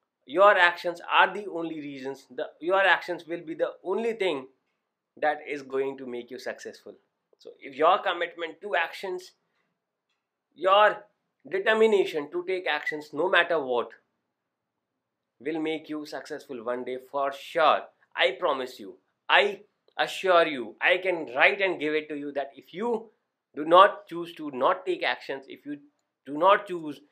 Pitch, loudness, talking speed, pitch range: 170 Hz, -25 LUFS, 160 wpm, 145-200 Hz